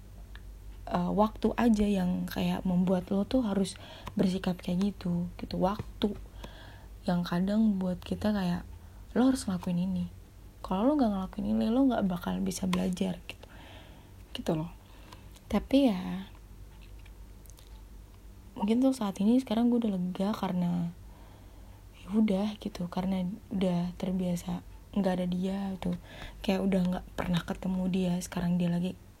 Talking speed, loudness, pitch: 135 wpm, -31 LUFS, 180 Hz